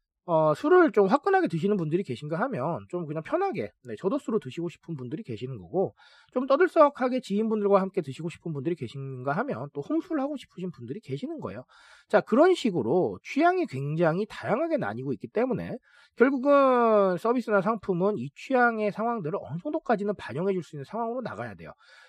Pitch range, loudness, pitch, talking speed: 165-260 Hz, -27 LUFS, 210 Hz, 415 characters per minute